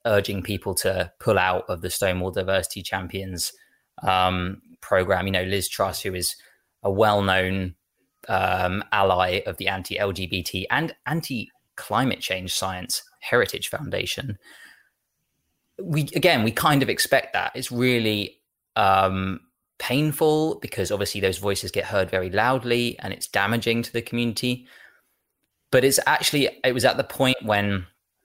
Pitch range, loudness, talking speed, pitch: 95-120 Hz, -23 LUFS, 145 wpm, 100 Hz